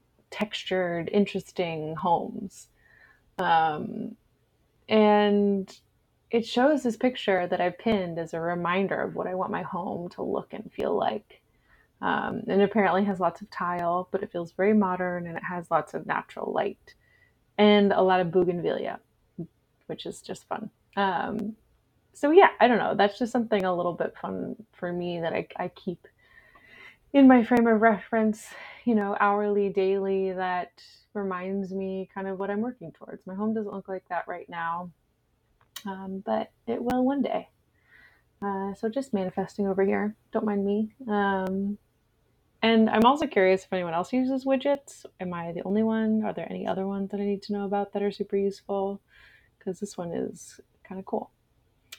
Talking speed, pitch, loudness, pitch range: 175 wpm, 200 Hz, -27 LUFS, 185-215 Hz